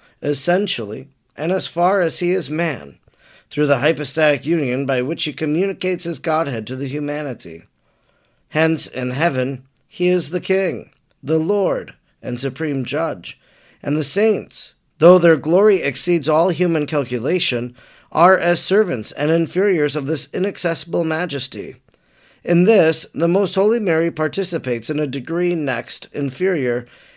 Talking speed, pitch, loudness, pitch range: 140 wpm, 160 Hz, -18 LUFS, 140-180 Hz